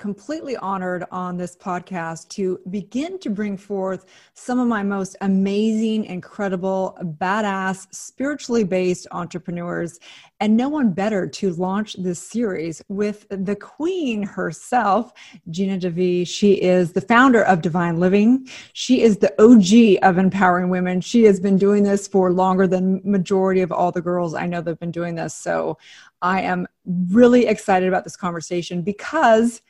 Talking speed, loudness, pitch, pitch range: 155 wpm, -19 LUFS, 195 Hz, 180-215 Hz